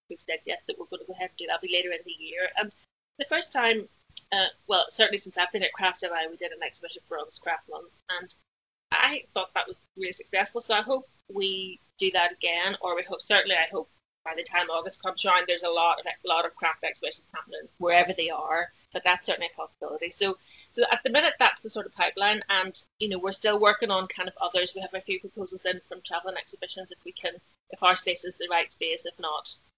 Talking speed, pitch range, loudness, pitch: 245 wpm, 180-210 Hz, -27 LUFS, 185 Hz